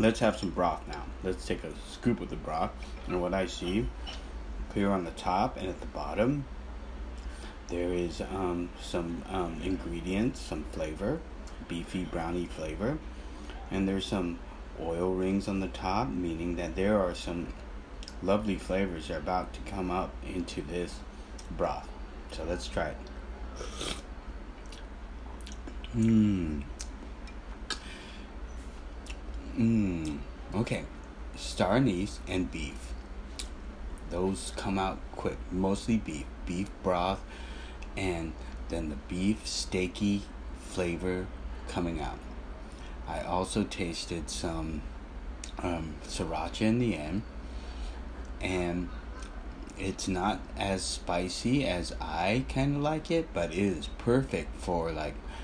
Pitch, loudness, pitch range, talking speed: 80 Hz, -33 LUFS, 70-95 Hz, 120 wpm